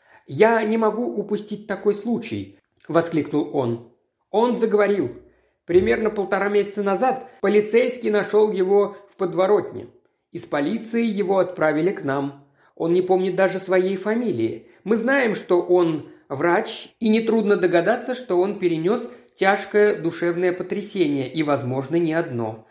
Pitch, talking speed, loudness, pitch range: 195 Hz, 130 wpm, -21 LUFS, 170-215 Hz